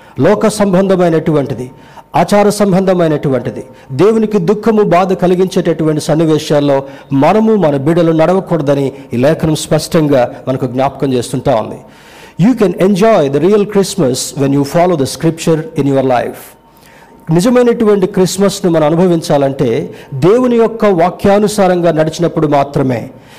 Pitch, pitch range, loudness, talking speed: 165 Hz, 140-190 Hz, -11 LUFS, 110 wpm